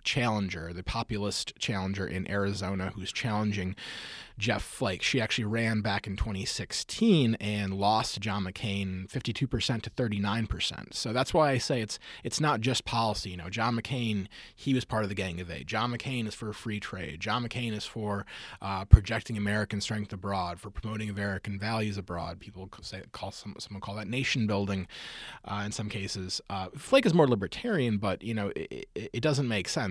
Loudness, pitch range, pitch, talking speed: -31 LUFS, 100-115 Hz, 105 Hz, 185 wpm